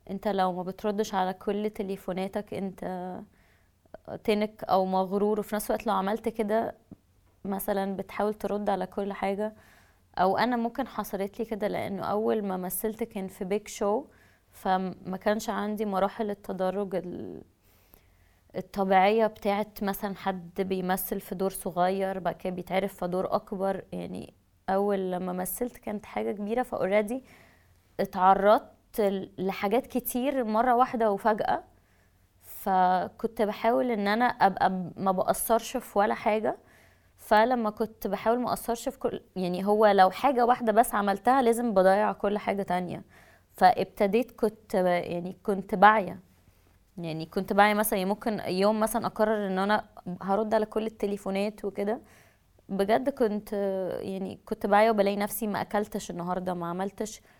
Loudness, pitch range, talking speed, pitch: -28 LUFS, 185-220 Hz, 140 wpm, 205 Hz